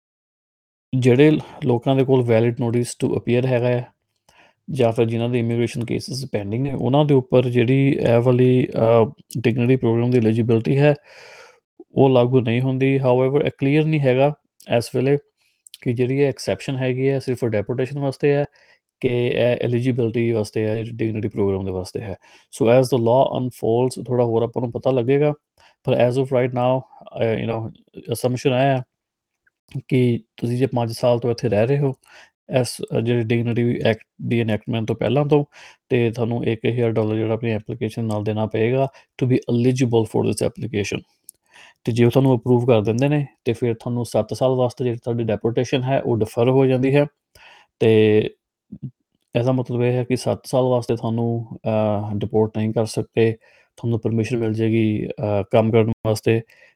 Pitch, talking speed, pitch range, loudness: 120 Hz, 165 wpm, 115-130 Hz, -20 LUFS